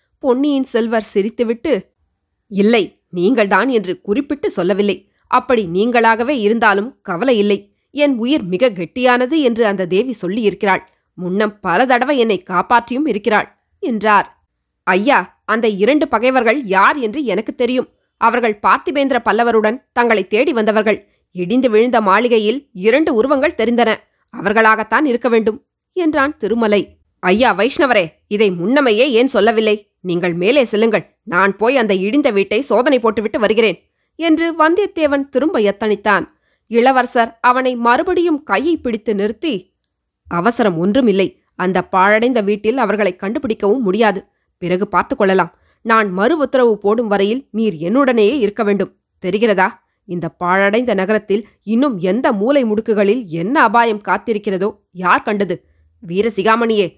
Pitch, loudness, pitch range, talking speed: 220 Hz, -15 LUFS, 200-245 Hz, 120 wpm